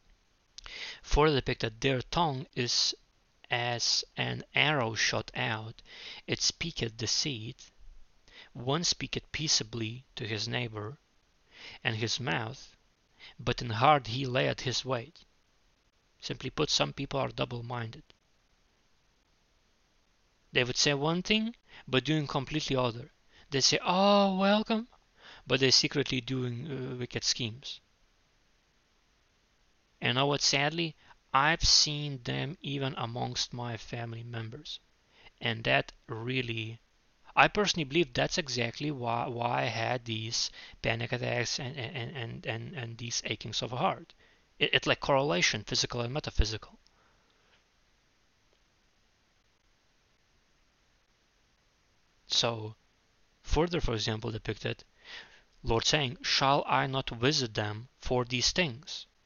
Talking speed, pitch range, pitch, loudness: 115 wpm, 115-145 Hz, 125 Hz, -30 LUFS